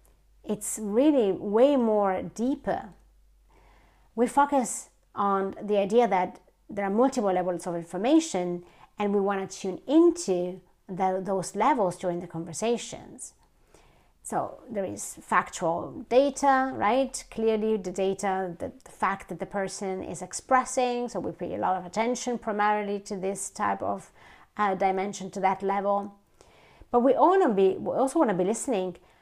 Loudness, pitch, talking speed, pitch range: -27 LUFS, 200 Hz, 150 wpm, 190-245 Hz